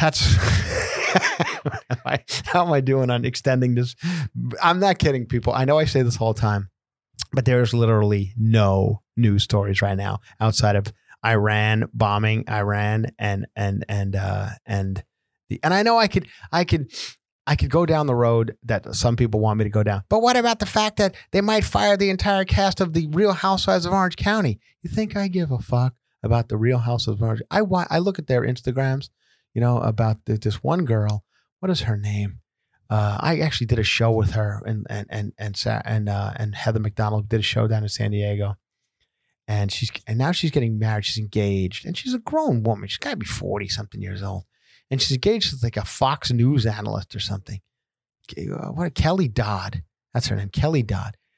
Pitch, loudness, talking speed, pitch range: 115 Hz, -22 LUFS, 205 wpm, 105-140 Hz